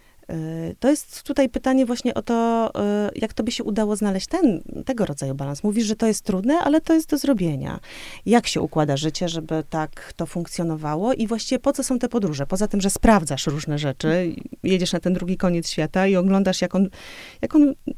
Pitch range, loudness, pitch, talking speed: 165-245 Hz, -22 LUFS, 200 Hz, 200 wpm